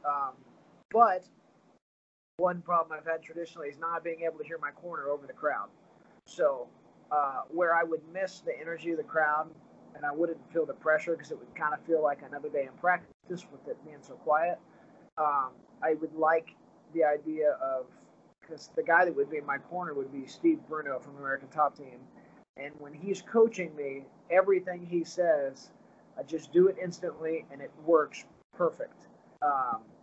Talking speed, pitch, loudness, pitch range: 185 wpm, 165 Hz, -31 LUFS, 150-185 Hz